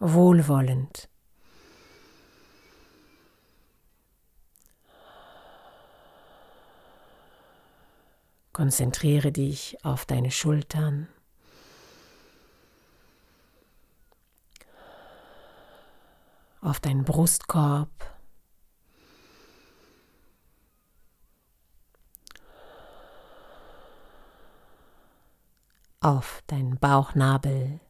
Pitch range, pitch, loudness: 125-150 Hz, 140 Hz, -25 LUFS